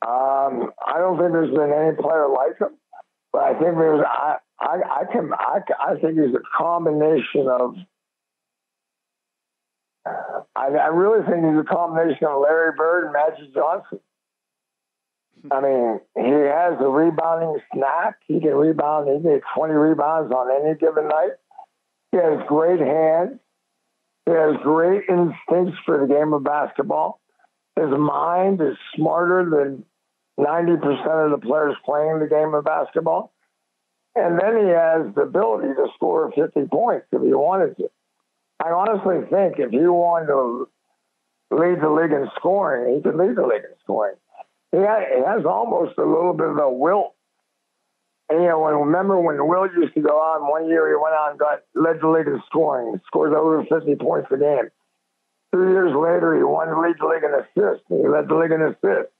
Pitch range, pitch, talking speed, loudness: 150-175 Hz, 160 Hz, 170 wpm, -20 LUFS